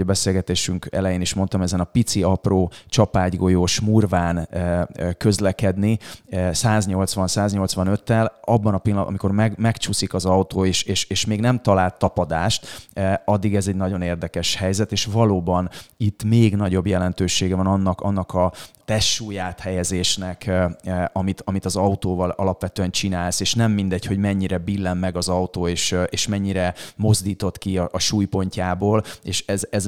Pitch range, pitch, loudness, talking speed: 90-100 Hz, 95 Hz, -21 LUFS, 145 wpm